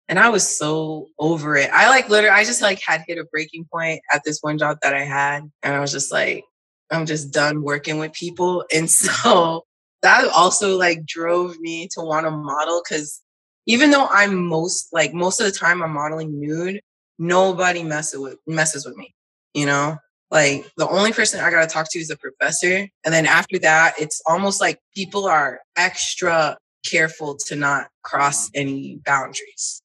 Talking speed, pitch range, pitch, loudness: 190 wpm, 150-180 Hz, 160 Hz, -18 LUFS